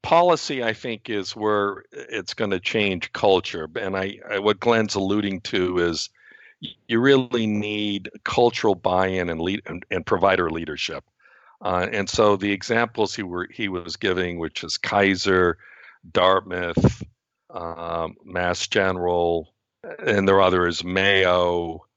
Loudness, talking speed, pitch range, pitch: -22 LUFS, 140 wpm, 90-105 Hz, 95 Hz